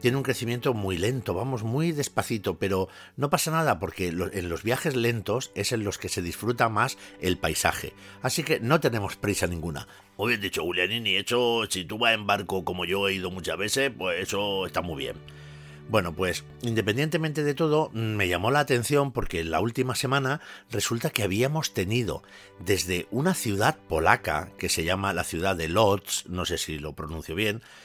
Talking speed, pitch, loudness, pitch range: 190 wpm, 105 Hz, -27 LUFS, 90-125 Hz